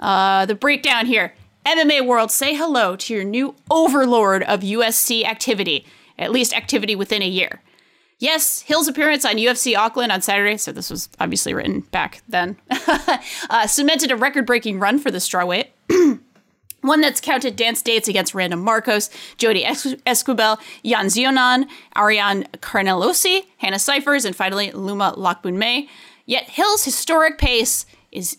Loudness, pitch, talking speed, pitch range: -18 LUFS, 245 Hz, 150 wpm, 205-285 Hz